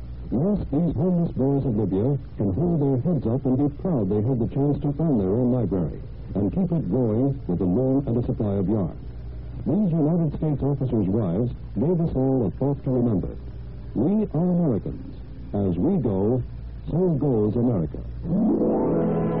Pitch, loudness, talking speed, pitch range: 130 Hz, -24 LUFS, 175 wpm, 105-150 Hz